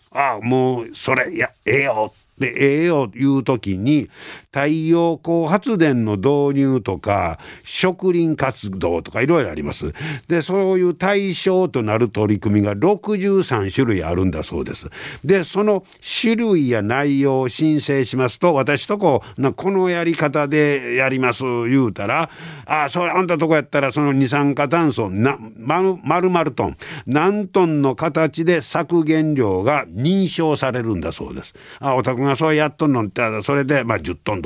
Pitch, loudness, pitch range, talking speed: 145 Hz, -18 LUFS, 125-170 Hz, 305 characters per minute